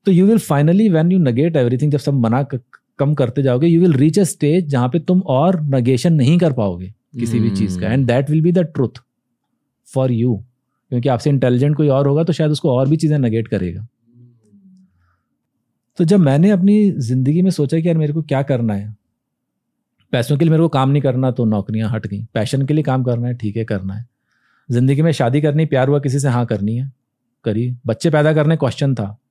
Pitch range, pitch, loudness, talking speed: 120-155 Hz, 135 Hz, -16 LUFS, 215 wpm